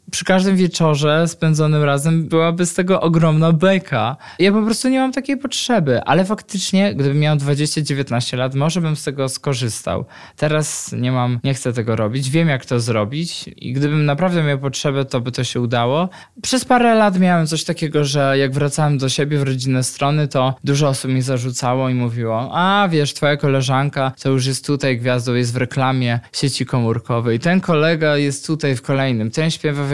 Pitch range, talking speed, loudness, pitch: 130-165 Hz, 190 wpm, -17 LUFS, 145 Hz